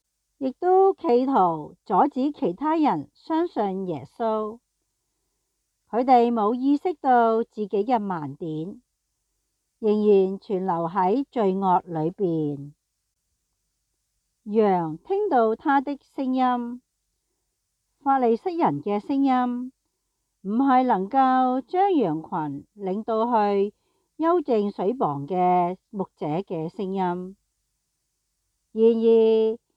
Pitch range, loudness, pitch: 185-255 Hz, -23 LUFS, 220 Hz